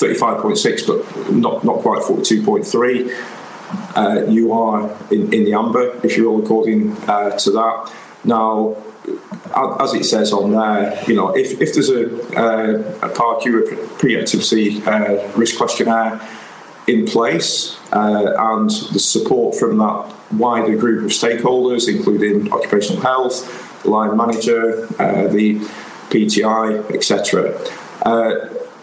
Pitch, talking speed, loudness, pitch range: 110 Hz, 125 wpm, -16 LUFS, 105-115 Hz